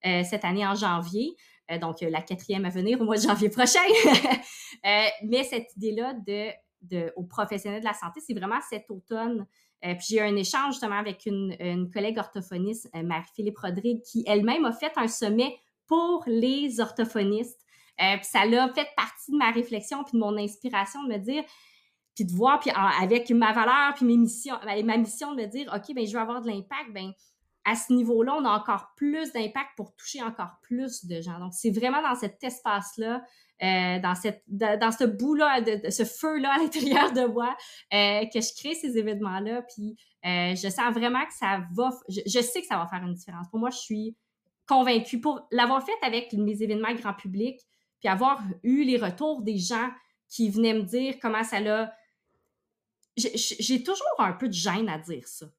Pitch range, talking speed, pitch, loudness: 200-250 Hz, 195 wpm, 225 Hz, -27 LUFS